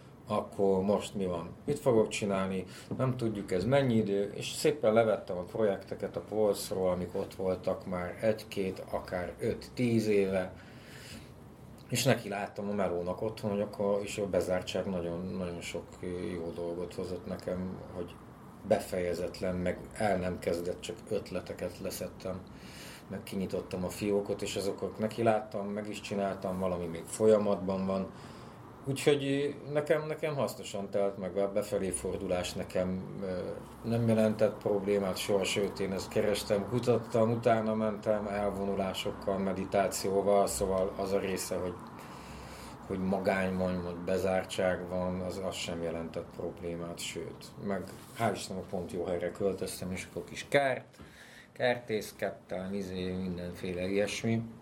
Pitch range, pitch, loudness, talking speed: 90-110 Hz, 100 Hz, -33 LUFS, 135 wpm